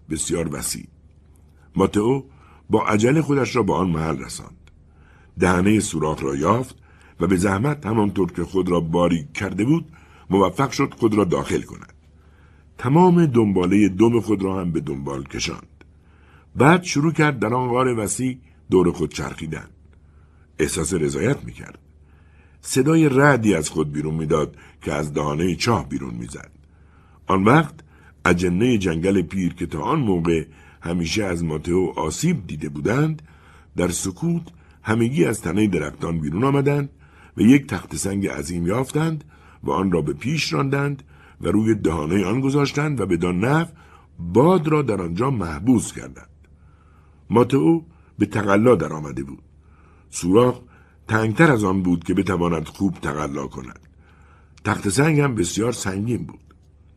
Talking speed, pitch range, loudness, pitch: 145 wpm, 80-120 Hz, -21 LUFS, 90 Hz